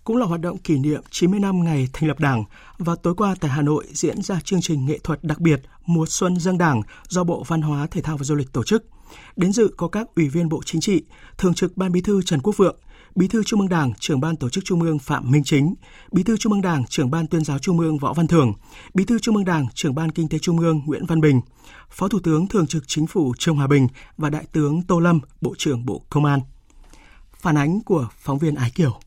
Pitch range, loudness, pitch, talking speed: 150-180 Hz, -21 LUFS, 160 Hz, 260 wpm